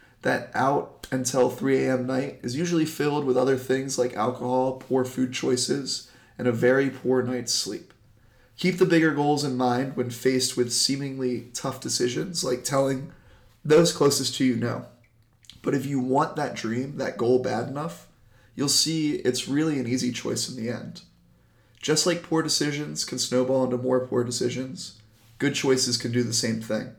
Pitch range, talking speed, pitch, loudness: 125-140 Hz, 175 wpm, 130 Hz, -25 LUFS